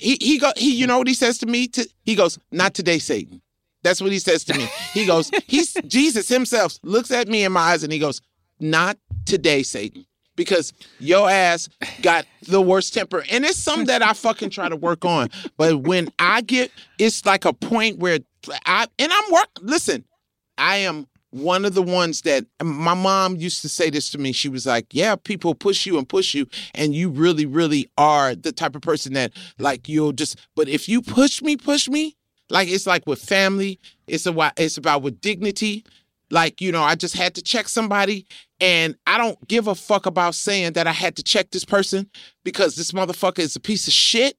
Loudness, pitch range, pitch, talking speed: -20 LUFS, 160-230 Hz, 185 Hz, 215 wpm